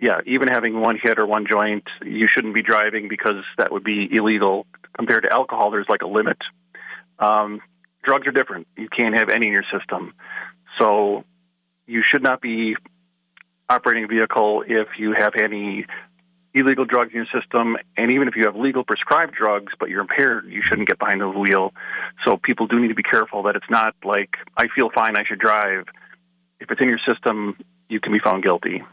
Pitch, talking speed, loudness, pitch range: 110 Hz, 200 wpm, -19 LUFS, 105-120 Hz